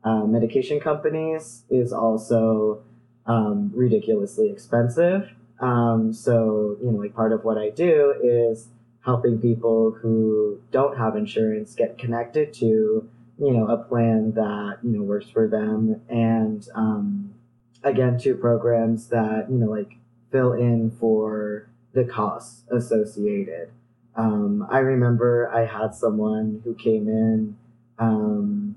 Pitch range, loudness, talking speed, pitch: 110-120 Hz, -22 LUFS, 130 wpm, 115 Hz